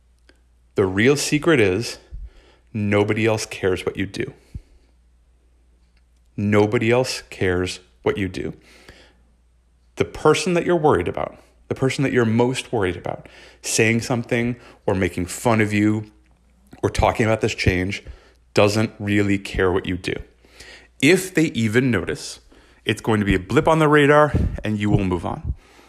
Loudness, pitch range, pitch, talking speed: -20 LUFS, 80-120 Hz, 105 Hz, 150 wpm